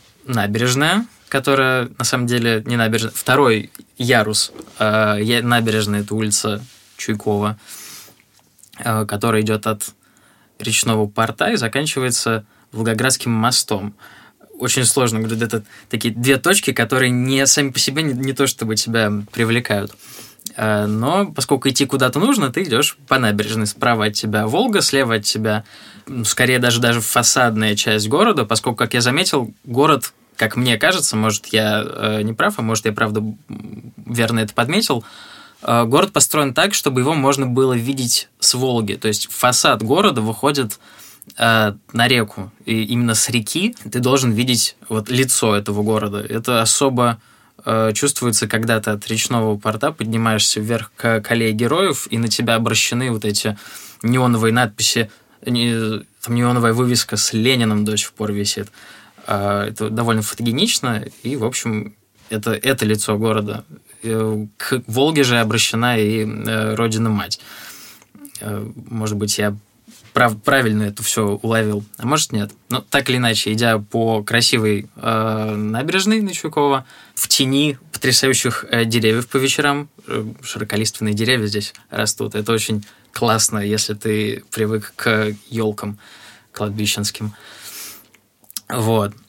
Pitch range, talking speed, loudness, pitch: 105-125 Hz, 130 wpm, -17 LUFS, 115 Hz